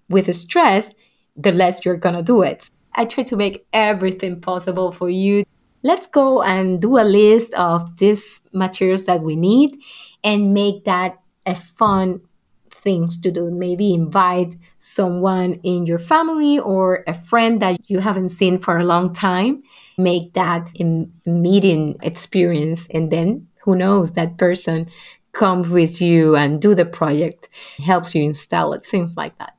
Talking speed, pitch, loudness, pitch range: 160 wpm, 185 Hz, -17 LUFS, 175-200 Hz